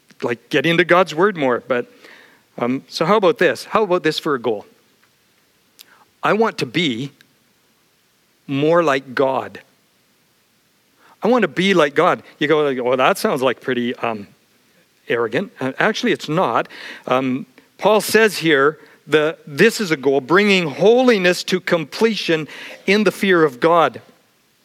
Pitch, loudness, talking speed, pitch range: 165 Hz, -17 LUFS, 150 wpm, 145-200 Hz